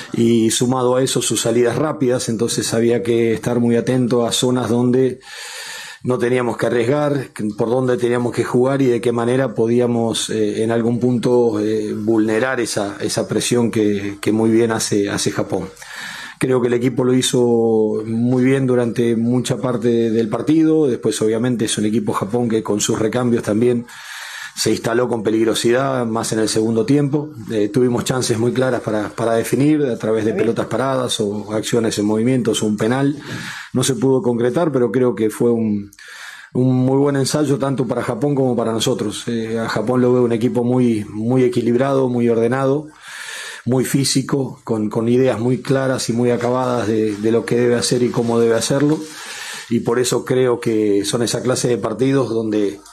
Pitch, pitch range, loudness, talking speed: 120 Hz, 115-130 Hz, -17 LUFS, 185 wpm